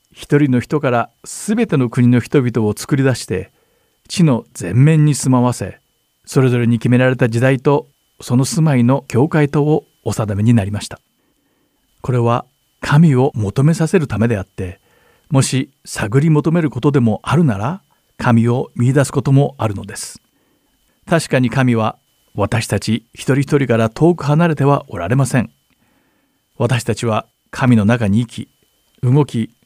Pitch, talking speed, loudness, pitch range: 125 Hz, 290 characters per minute, -16 LUFS, 115-145 Hz